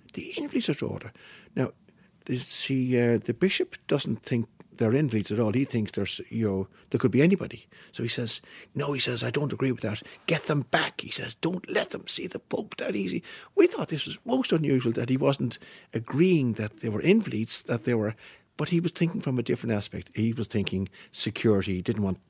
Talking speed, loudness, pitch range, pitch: 210 wpm, -28 LUFS, 110-150 Hz, 125 Hz